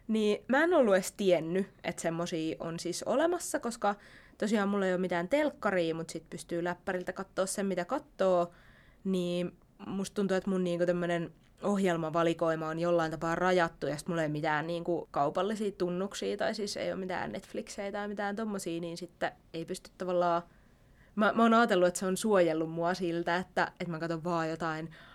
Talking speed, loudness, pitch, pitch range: 185 wpm, -32 LUFS, 180 Hz, 170-200 Hz